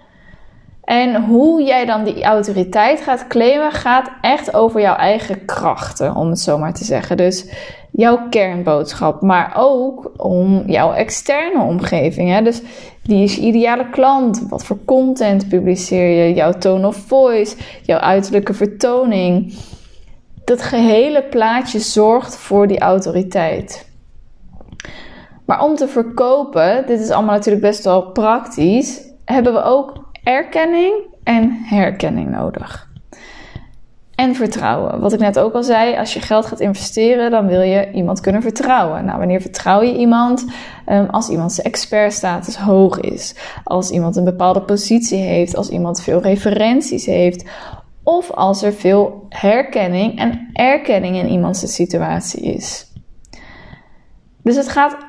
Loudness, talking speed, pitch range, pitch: -15 LUFS, 140 wpm, 190-250 Hz, 215 Hz